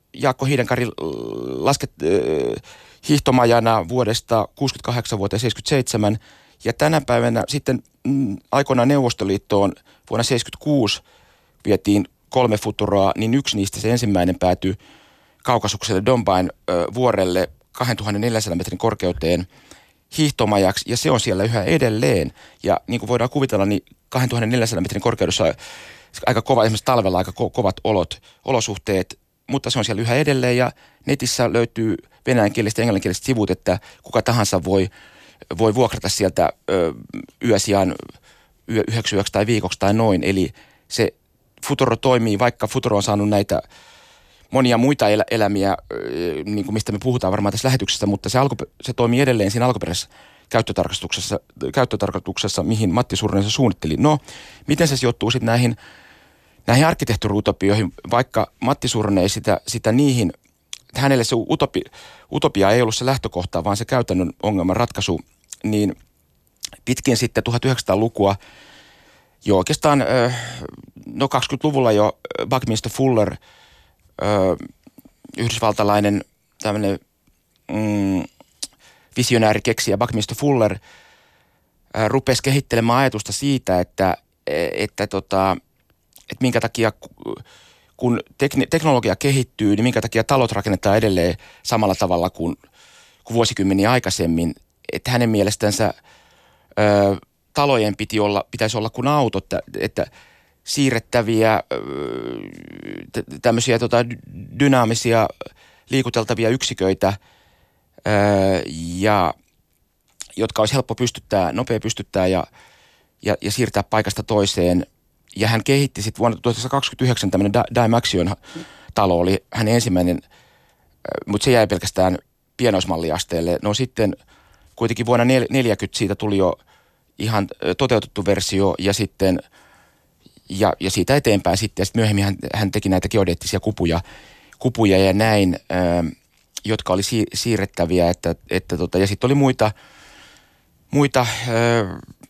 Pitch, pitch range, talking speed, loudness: 110 Hz, 100-125 Hz, 120 wpm, -20 LUFS